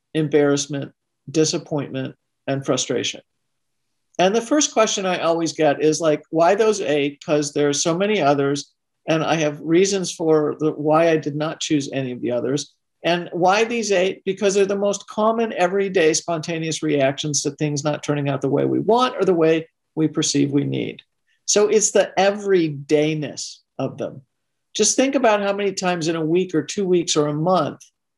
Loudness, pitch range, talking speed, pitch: -20 LUFS, 145-190 Hz, 185 wpm, 155 Hz